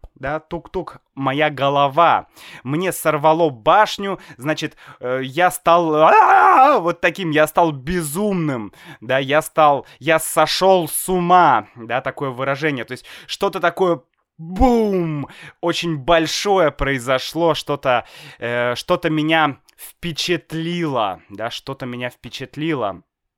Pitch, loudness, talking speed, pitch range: 155 Hz, -18 LUFS, 110 wpm, 140-175 Hz